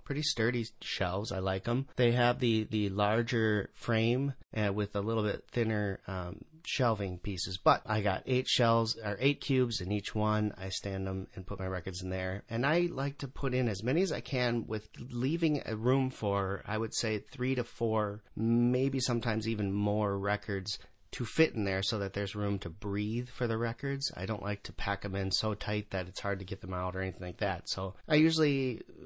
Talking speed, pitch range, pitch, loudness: 215 wpm, 100-125 Hz, 110 Hz, -33 LUFS